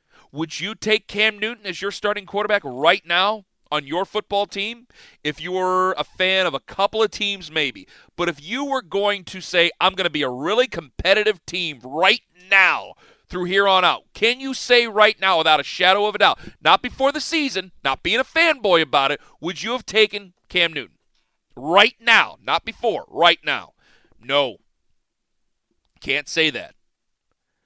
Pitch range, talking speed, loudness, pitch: 170-215 Hz, 180 wpm, -19 LUFS, 195 Hz